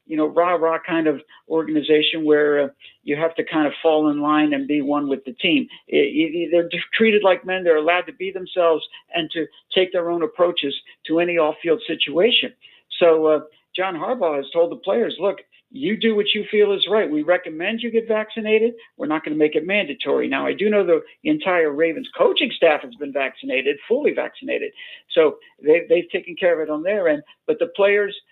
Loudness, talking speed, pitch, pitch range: -20 LUFS, 210 wpm, 175 Hz, 155-220 Hz